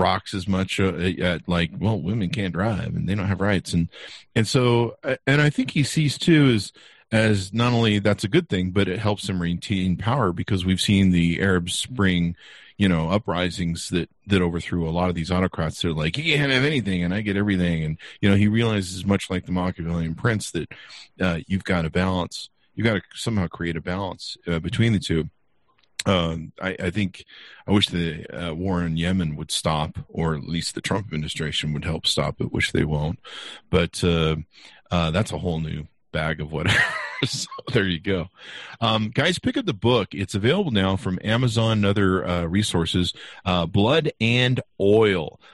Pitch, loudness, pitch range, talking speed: 95 Hz, -23 LUFS, 85-110 Hz, 200 wpm